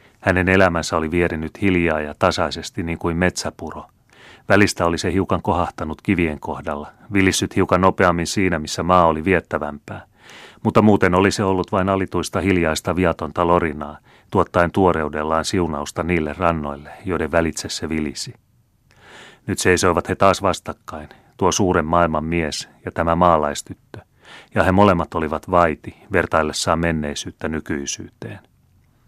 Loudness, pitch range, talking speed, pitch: -19 LUFS, 80-95 Hz, 130 wpm, 85 Hz